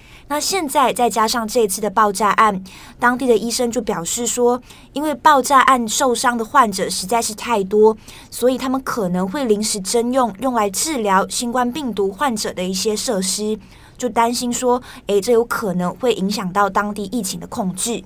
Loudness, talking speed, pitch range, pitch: -18 LUFS, 275 characters per minute, 205-245 Hz, 230 Hz